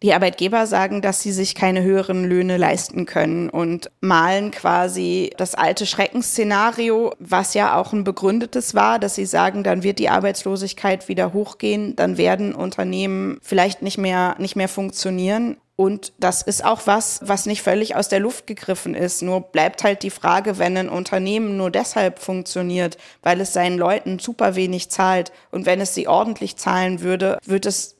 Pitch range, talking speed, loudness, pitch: 180-200 Hz, 175 wpm, -20 LUFS, 190 Hz